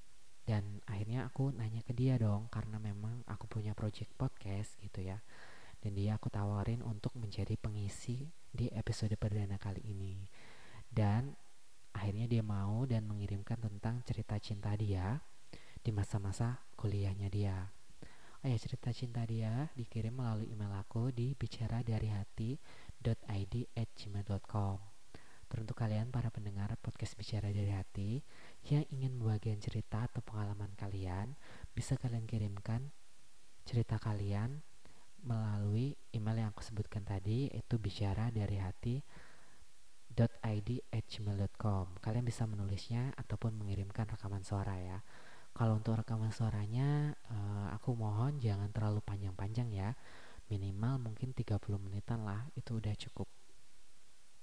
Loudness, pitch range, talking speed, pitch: -40 LUFS, 100-120 Hz, 120 wpm, 110 Hz